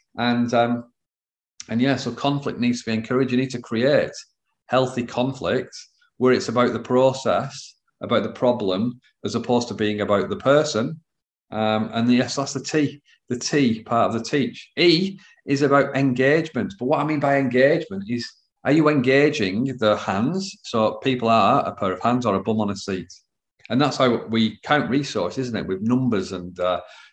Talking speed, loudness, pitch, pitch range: 190 wpm, -22 LUFS, 125 Hz, 115-140 Hz